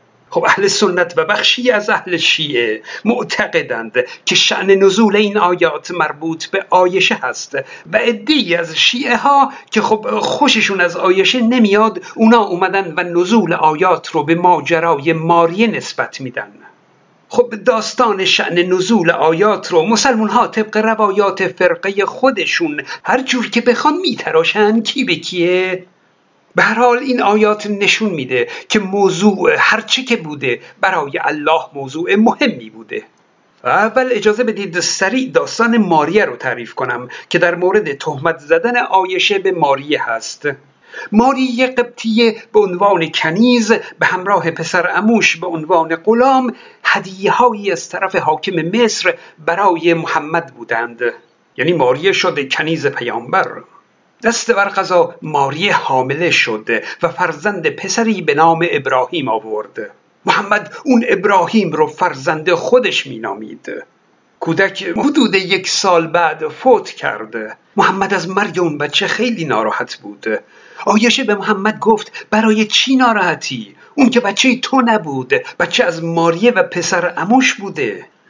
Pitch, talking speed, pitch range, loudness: 210 Hz, 135 wpm, 175-240 Hz, -14 LUFS